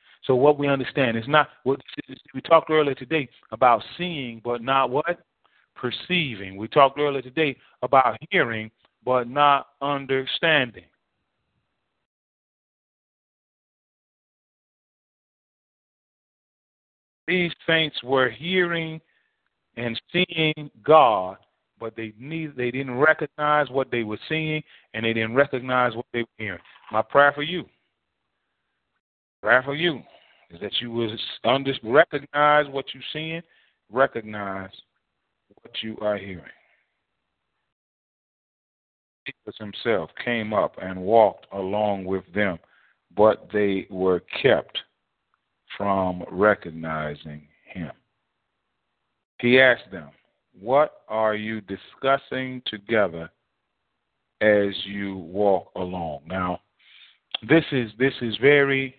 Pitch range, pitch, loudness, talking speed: 105-145 Hz, 125 Hz, -23 LUFS, 105 wpm